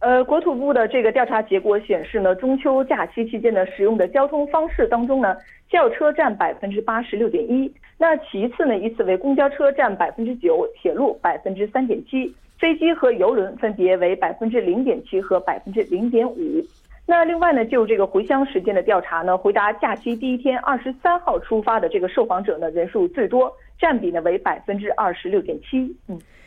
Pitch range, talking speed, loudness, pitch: 205-300 Hz, 315 characters per minute, -20 LUFS, 245 Hz